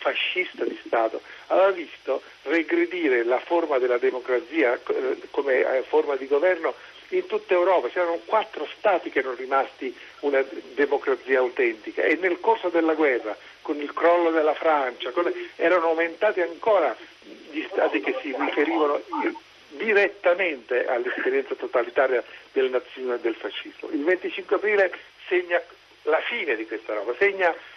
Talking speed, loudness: 135 wpm, -24 LUFS